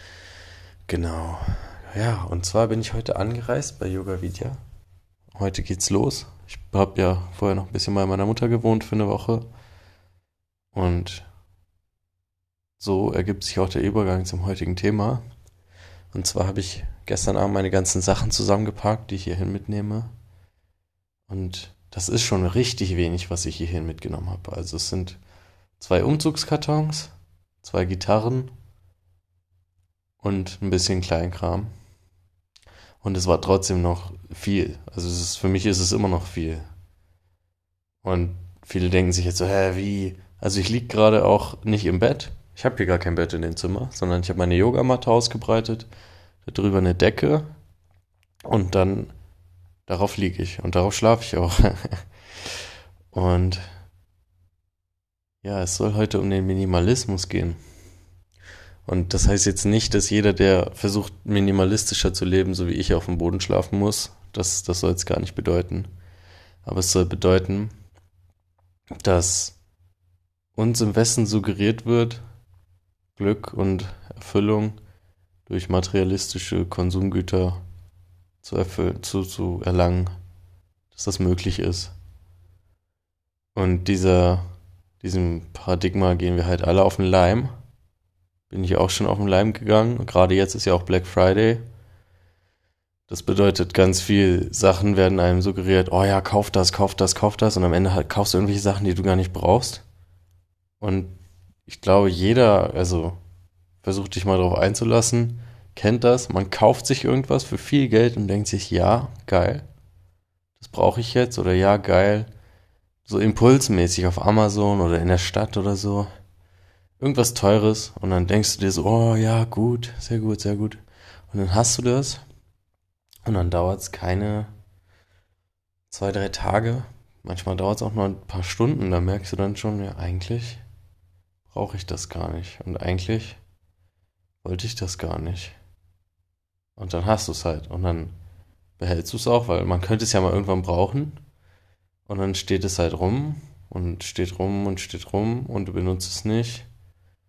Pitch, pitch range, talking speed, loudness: 95 Hz, 90-105 Hz, 155 wpm, -22 LUFS